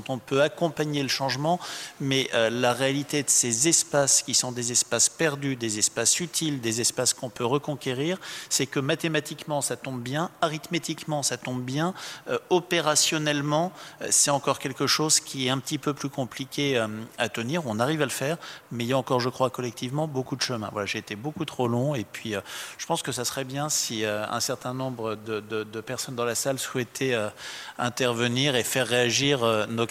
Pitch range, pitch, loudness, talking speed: 120-150 Hz, 135 Hz, -26 LUFS, 210 wpm